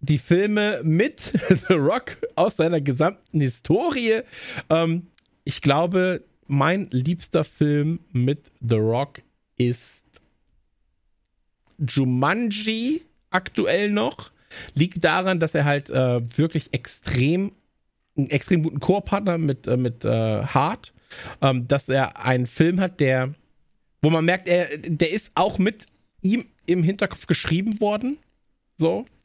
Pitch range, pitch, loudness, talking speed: 135-185 Hz, 160 Hz, -23 LUFS, 125 wpm